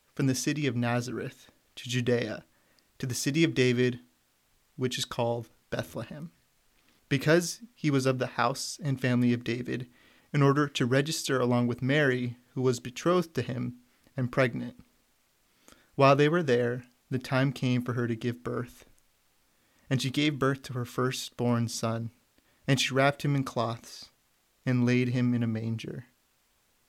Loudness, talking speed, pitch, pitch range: -29 LUFS, 160 wpm, 125 Hz, 120-135 Hz